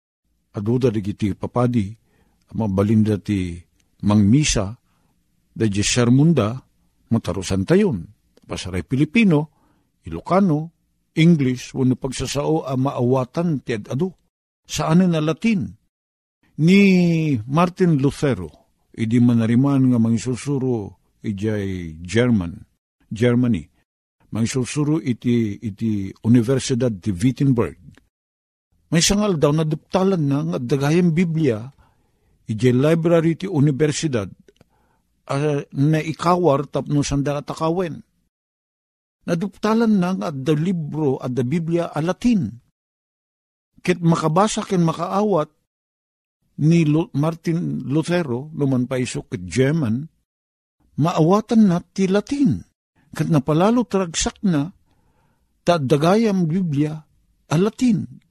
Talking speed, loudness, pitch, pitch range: 105 wpm, -20 LUFS, 140 Hz, 115-165 Hz